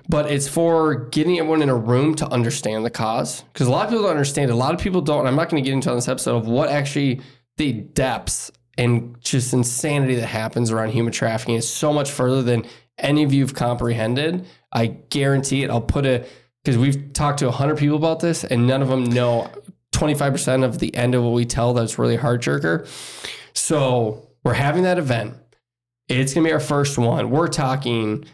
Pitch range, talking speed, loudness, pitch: 120-150 Hz, 220 wpm, -20 LUFS, 130 Hz